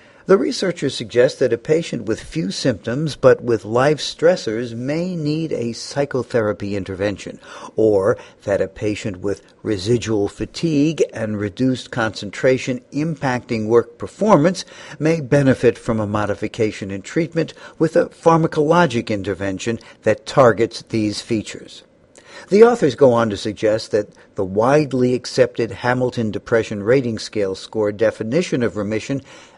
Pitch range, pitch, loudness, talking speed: 110-150 Hz, 120 Hz, -19 LUFS, 130 wpm